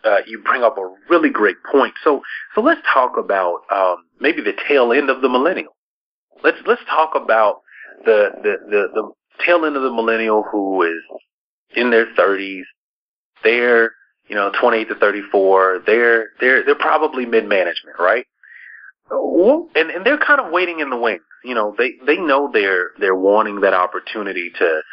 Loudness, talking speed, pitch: -16 LUFS, 180 wpm, 120 Hz